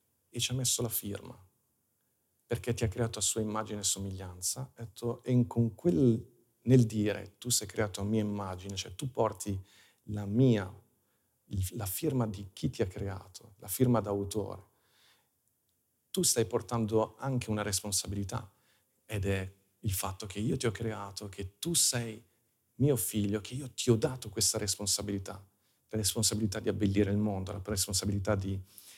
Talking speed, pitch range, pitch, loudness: 160 wpm, 100-115 Hz, 110 Hz, -32 LUFS